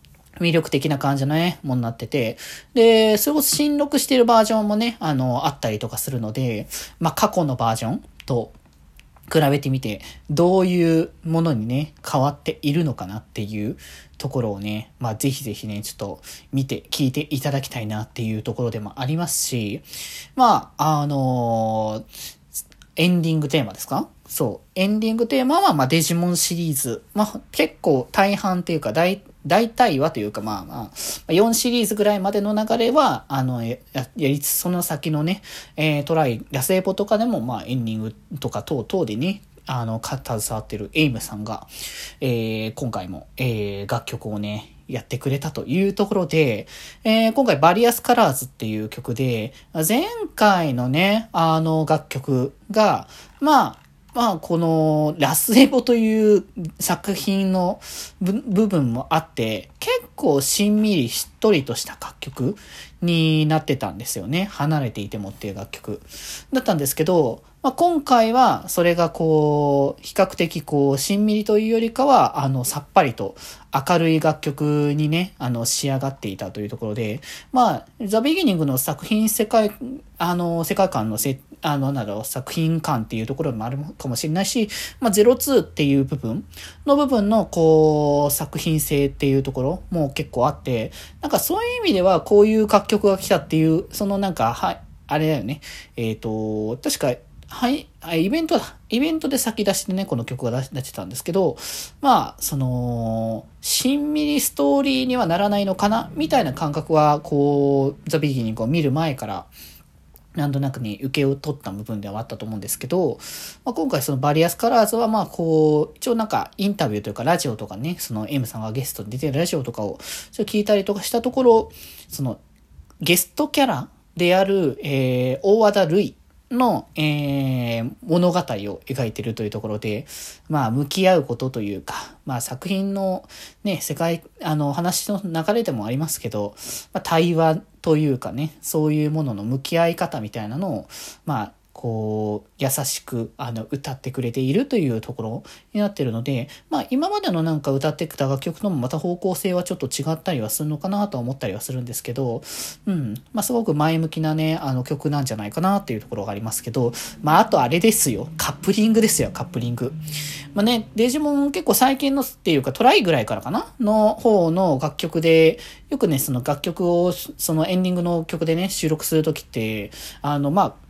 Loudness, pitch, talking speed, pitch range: -21 LUFS, 155 Hz, 360 characters per minute, 125-195 Hz